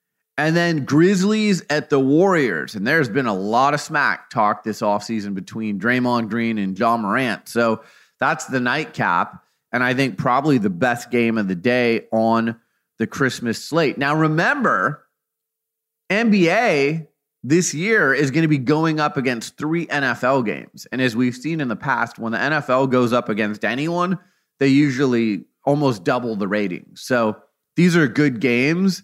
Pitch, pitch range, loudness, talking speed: 135 Hz, 115-160 Hz, -19 LUFS, 165 wpm